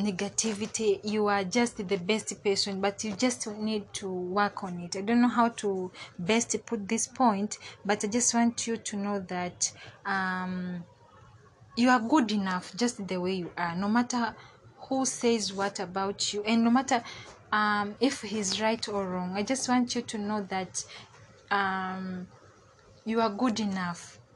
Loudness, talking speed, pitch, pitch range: -29 LUFS, 170 wpm, 205 Hz, 185-230 Hz